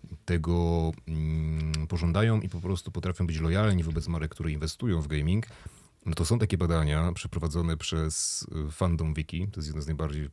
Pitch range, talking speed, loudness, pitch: 80-90 Hz, 165 wpm, -29 LUFS, 85 Hz